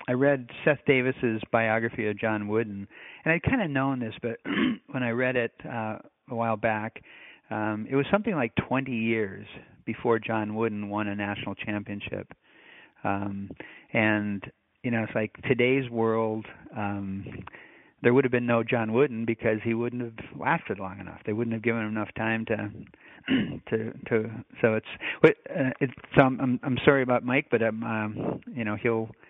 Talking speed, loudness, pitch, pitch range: 175 wpm, -27 LUFS, 115 Hz, 110-125 Hz